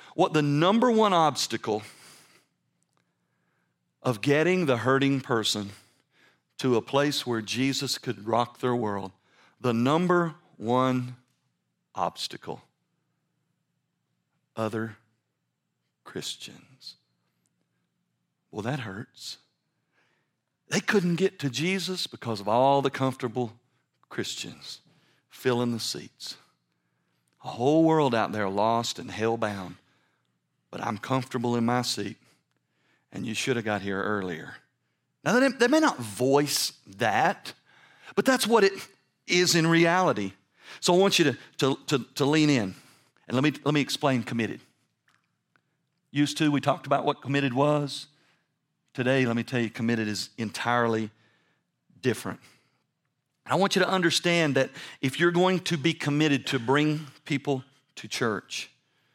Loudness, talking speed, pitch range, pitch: -26 LUFS, 130 wpm, 115-155 Hz, 135 Hz